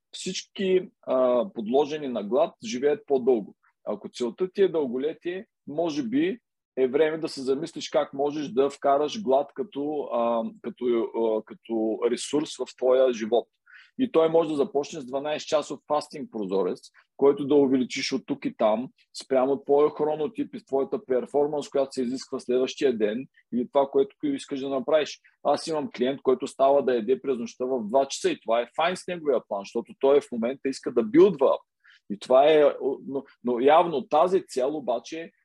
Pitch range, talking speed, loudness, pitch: 130-165 Hz, 175 wpm, -26 LUFS, 140 Hz